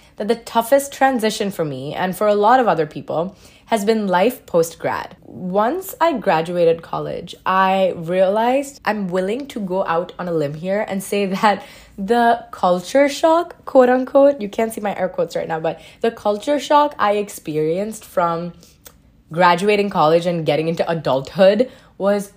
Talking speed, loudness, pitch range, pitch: 170 wpm, -18 LUFS, 175-235 Hz, 200 Hz